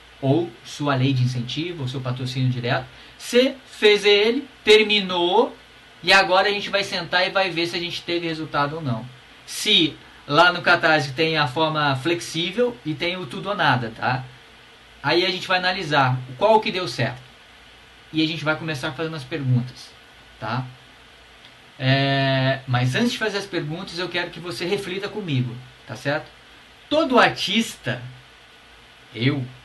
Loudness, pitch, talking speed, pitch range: -21 LUFS, 160 Hz, 160 wpm, 130-185 Hz